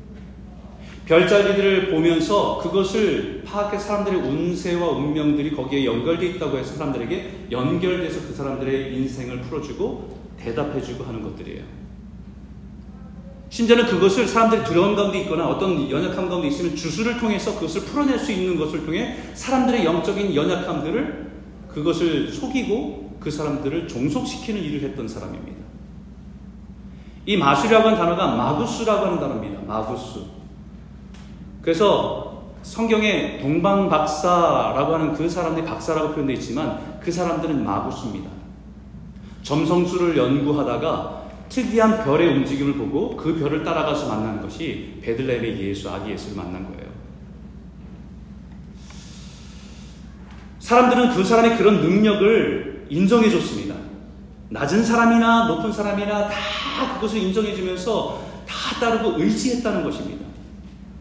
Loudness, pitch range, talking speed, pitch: -21 LUFS, 145-215 Hz, 320 characters per minute, 175 Hz